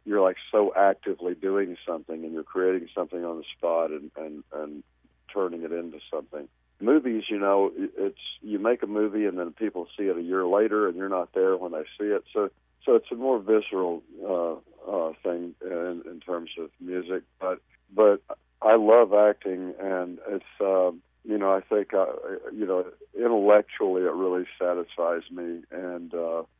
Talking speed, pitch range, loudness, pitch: 185 wpm, 85-105 Hz, -26 LUFS, 90 Hz